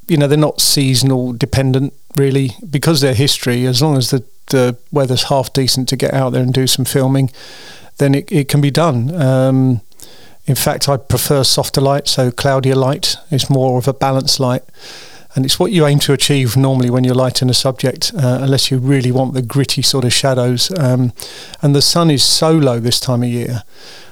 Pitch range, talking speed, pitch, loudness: 130-140 Hz, 205 wpm, 135 Hz, -13 LUFS